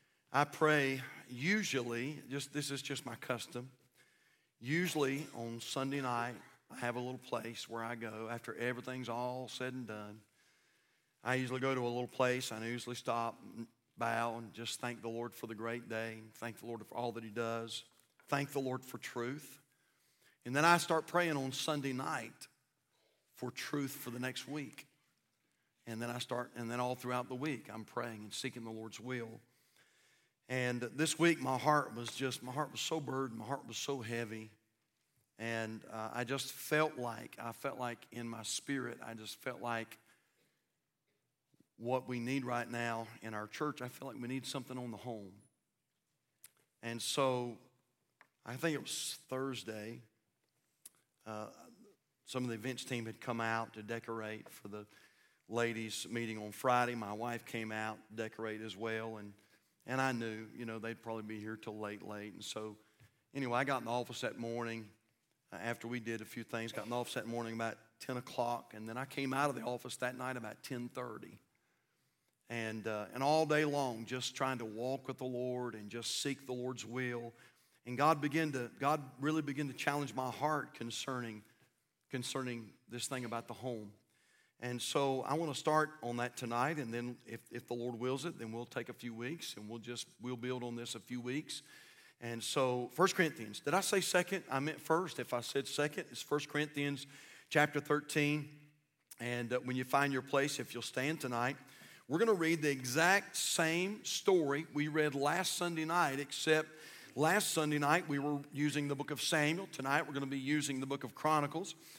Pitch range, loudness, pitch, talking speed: 115-140 Hz, -38 LUFS, 125 Hz, 190 wpm